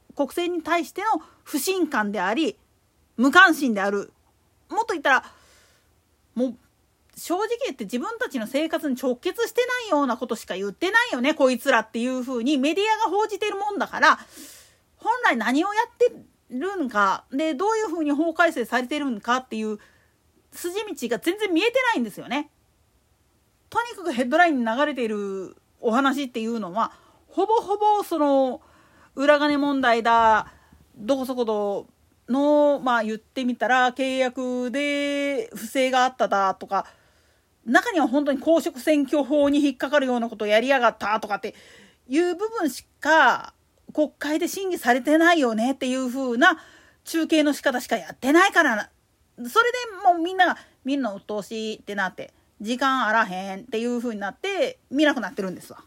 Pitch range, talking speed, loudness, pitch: 235-340 Hz, 340 characters per minute, -23 LUFS, 280 Hz